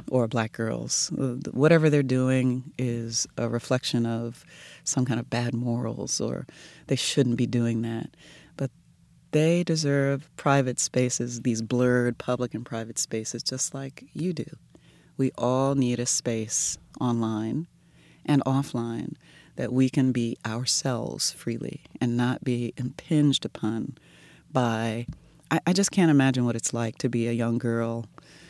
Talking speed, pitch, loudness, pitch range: 145 wpm, 125 Hz, -26 LUFS, 115-135 Hz